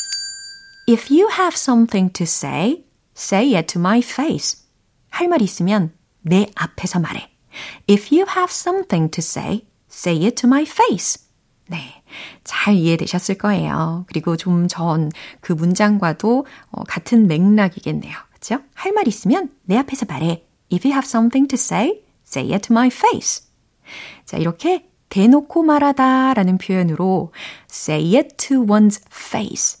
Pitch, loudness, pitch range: 210 Hz, -17 LUFS, 180-275 Hz